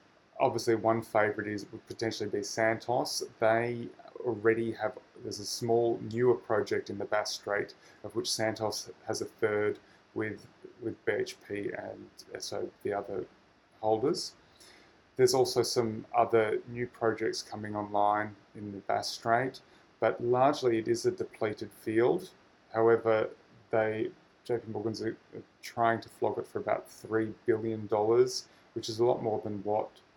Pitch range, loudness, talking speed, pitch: 110-125 Hz, -31 LUFS, 145 wpm, 115 Hz